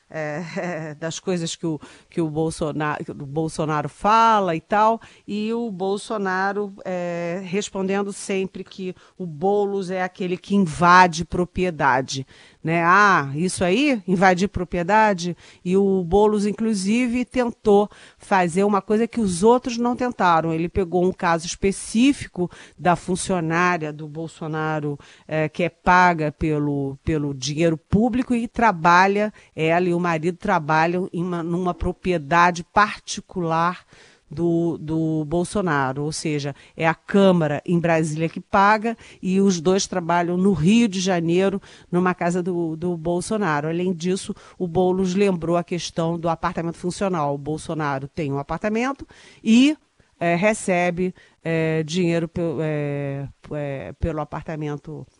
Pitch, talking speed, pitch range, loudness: 180 Hz, 135 wpm, 160-195 Hz, -21 LUFS